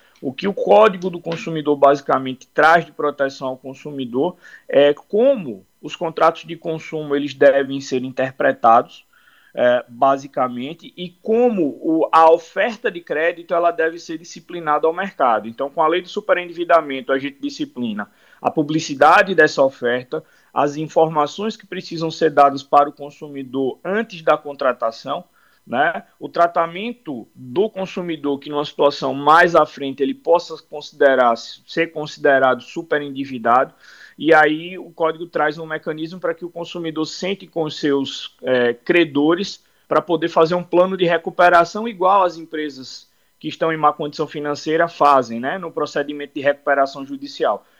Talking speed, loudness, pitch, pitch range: 150 wpm, -18 LUFS, 155 Hz, 140-175 Hz